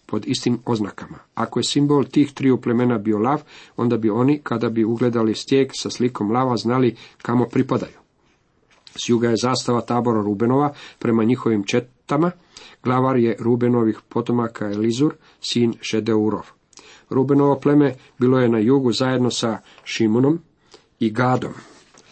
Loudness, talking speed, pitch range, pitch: -20 LUFS, 140 wpm, 115-130 Hz, 120 Hz